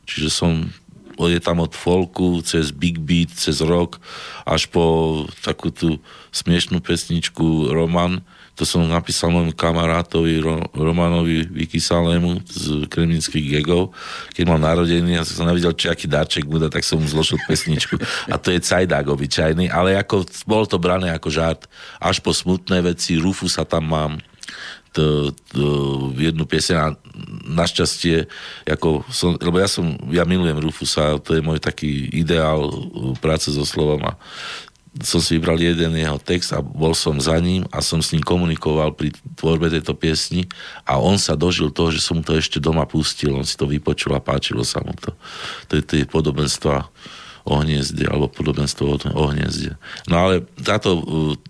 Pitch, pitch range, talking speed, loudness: 80 Hz, 75-85 Hz, 165 wpm, -19 LUFS